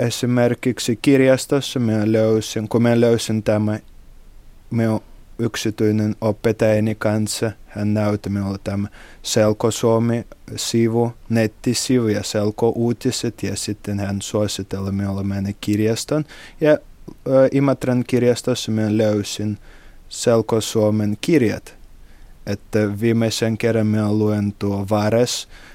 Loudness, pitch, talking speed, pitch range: -20 LUFS, 110 Hz, 105 wpm, 105-115 Hz